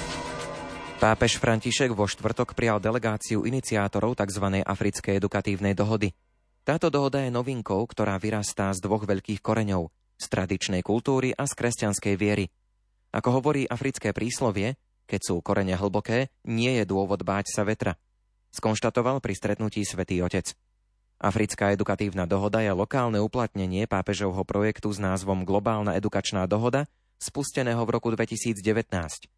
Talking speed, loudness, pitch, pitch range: 130 wpm, -27 LUFS, 105 Hz, 100-115 Hz